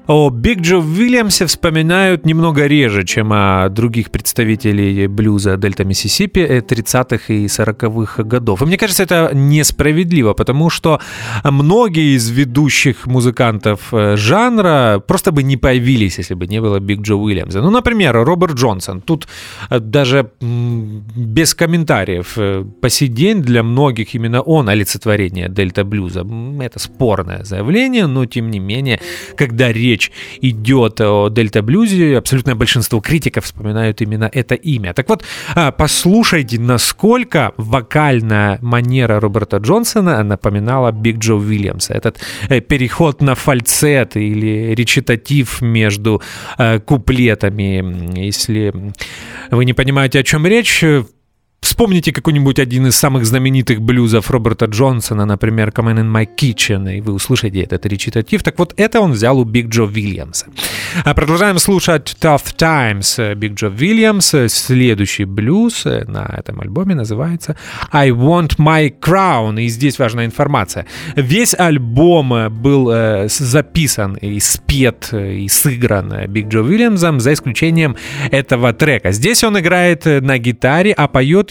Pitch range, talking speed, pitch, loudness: 110-150 Hz, 130 wpm, 125 Hz, -13 LUFS